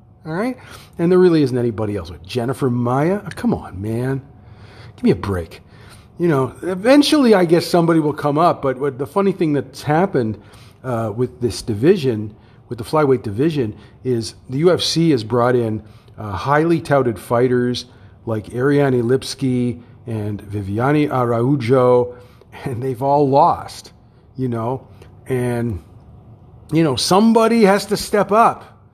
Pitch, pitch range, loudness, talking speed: 125 Hz, 110-145 Hz, -18 LUFS, 150 wpm